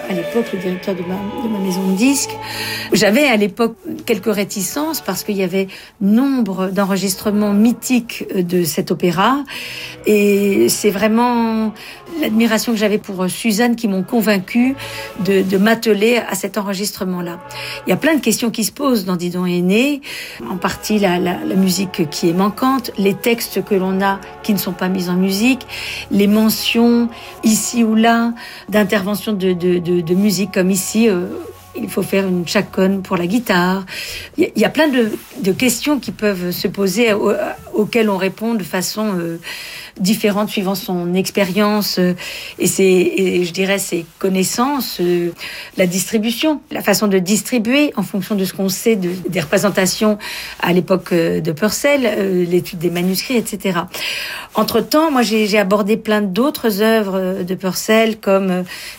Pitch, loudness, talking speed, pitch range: 205 Hz, -17 LUFS, 170 wpm, 185-225 Hz